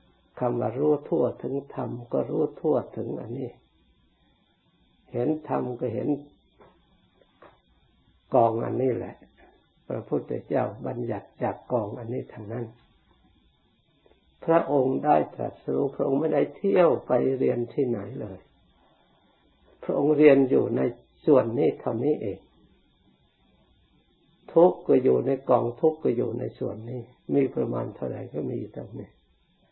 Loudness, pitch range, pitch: -26 LUFS, 115-140 Hz, 125 Hz